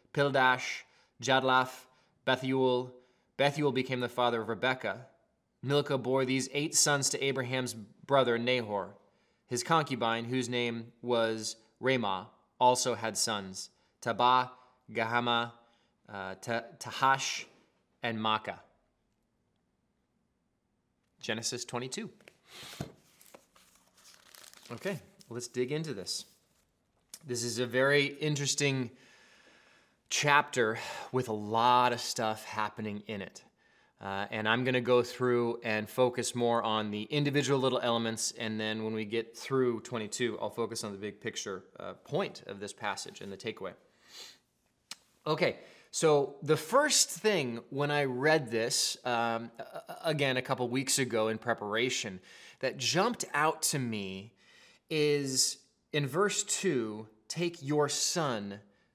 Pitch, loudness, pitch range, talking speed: 125 Hz, -31 LUFS, 115-135 Hz, 120 wpm